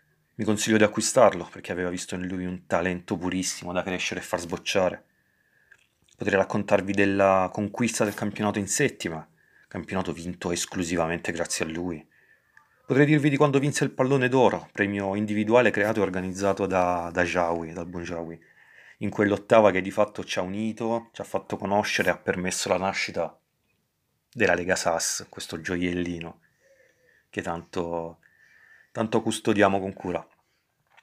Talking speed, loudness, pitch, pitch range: 150 wpm, -25 LUFS, 95 Hz, 90-105 Hz